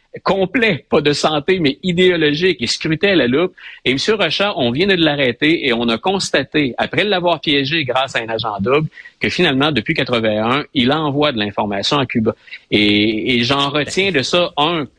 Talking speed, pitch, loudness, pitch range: 185 wpm, 150 Hz, -16 LUFS, 125-180 Hz